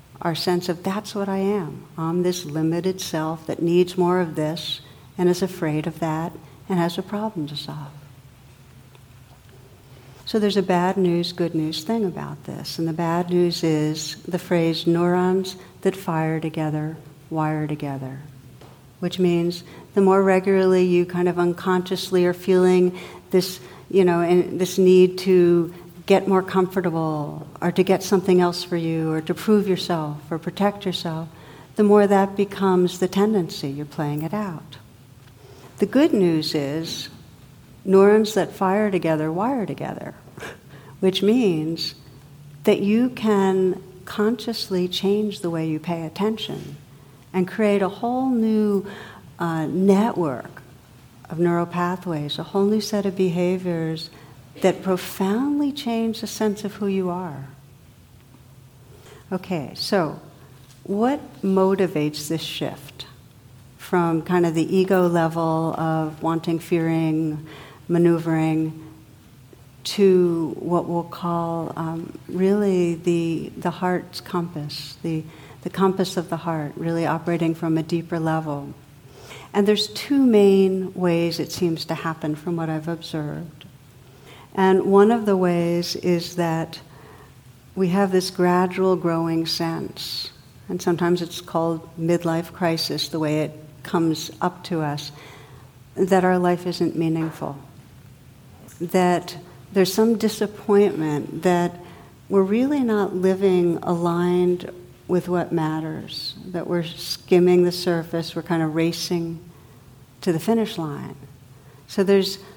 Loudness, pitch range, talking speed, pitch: -22 LUFS, 155-185 Hz, 135 wpm, 170 Hz